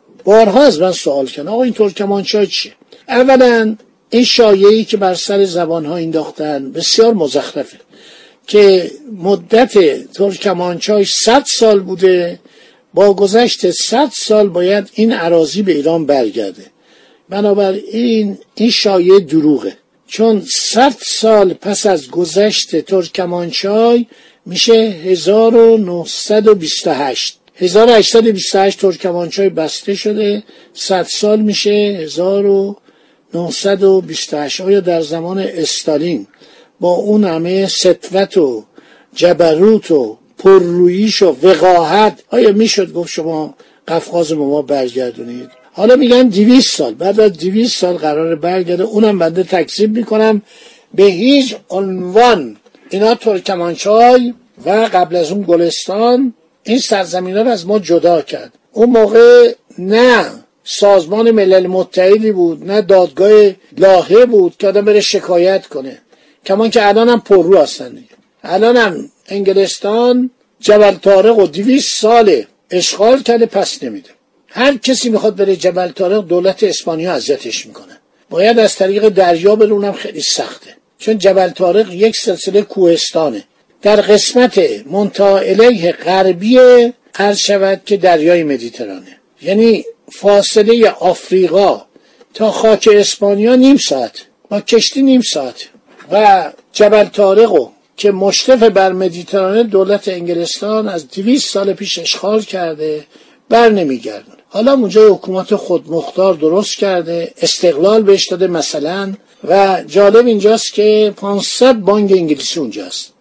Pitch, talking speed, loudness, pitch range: 200 Hz, 120 wpm, -11 LUFS, 180-220 Hz